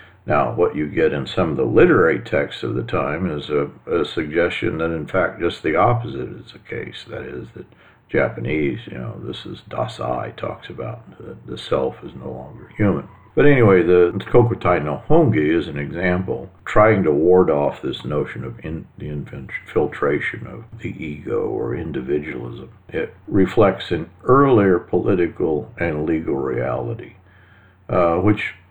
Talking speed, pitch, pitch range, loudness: 165 wpm, 90 Hz, 80-105 Hz, -19 LUFS